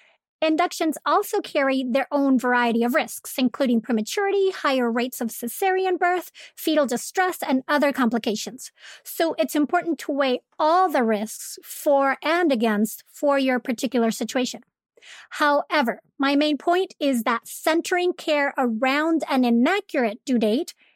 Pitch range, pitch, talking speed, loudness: 245-330 Hz, 280 Hz, 135 wpm, -22 LUFS